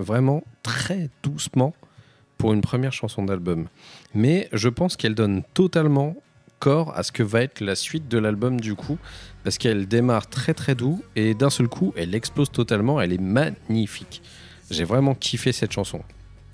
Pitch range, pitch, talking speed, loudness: 105-140 Hz, 120 Hz, 170 wpm, -23 LUFS